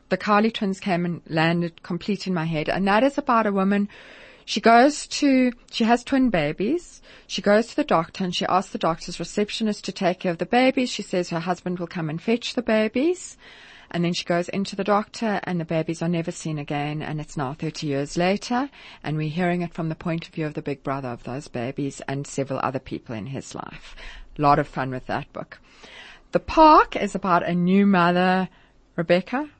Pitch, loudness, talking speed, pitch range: 180 Hz, -23 LUFS, 220 wpm, 165-215 Hz